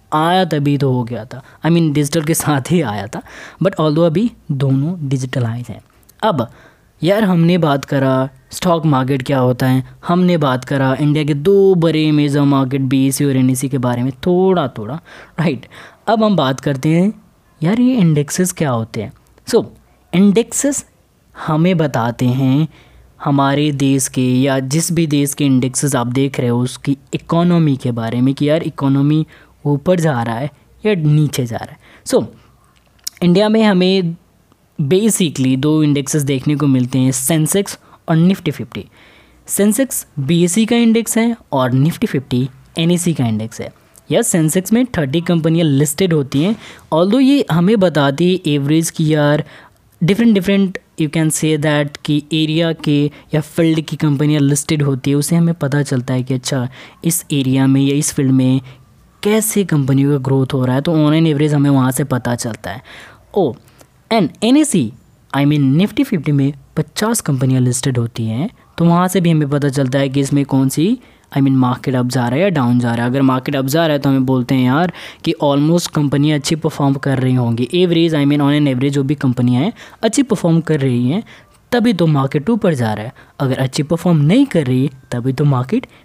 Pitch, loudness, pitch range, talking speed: 145 Hz, -15 LUFS, 135-170 Hz, 195 wpm